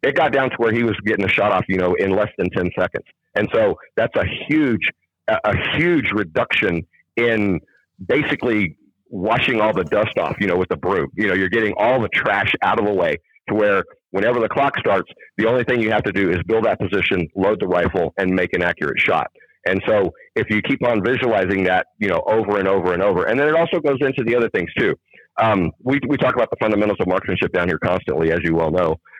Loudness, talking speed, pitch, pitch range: -19 LUFS, 235 wpm, 110 Hz, 95-120 Hz